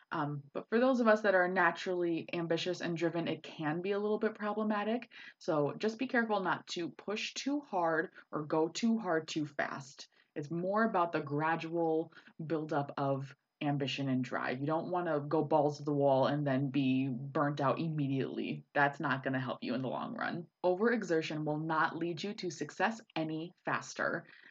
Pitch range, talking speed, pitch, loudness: 145-185 Hz, 190 wpm, 160 Hz, -34 LUFS